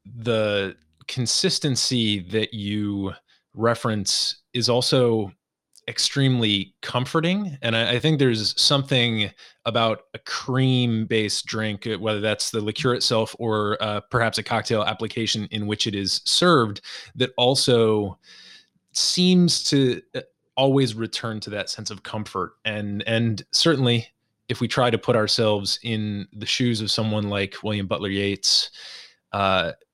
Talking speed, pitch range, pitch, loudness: 130 wpm, 105-125 Hz, 110 Hz, -22 LUFS